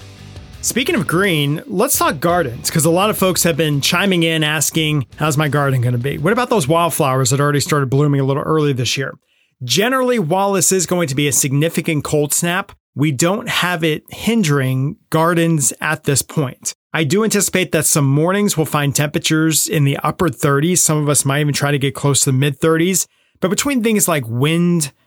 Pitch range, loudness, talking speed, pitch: 145-175 Hz, -16 LUFS, 205 wpm, 155 Hz